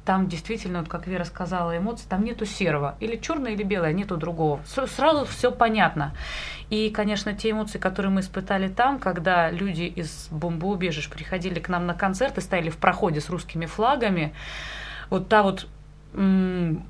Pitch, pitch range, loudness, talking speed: 185 Hz, 170-210 Hz, -25 LUFS, 165 wpm